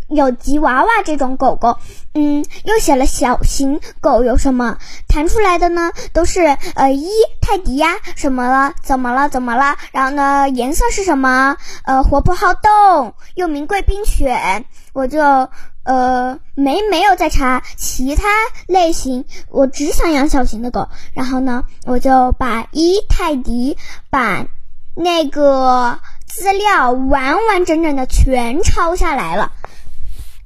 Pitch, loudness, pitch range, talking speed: 285 Hz, -15 LUFS, 260-355 Hz, 200 characters per minute